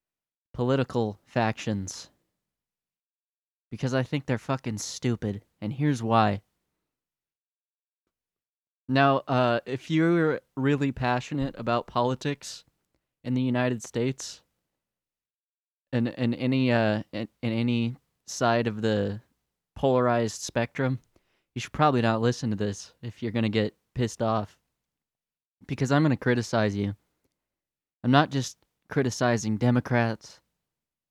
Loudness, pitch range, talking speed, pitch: -27 LUFS, 110-130 Hz, 110 wpm, 120 Hz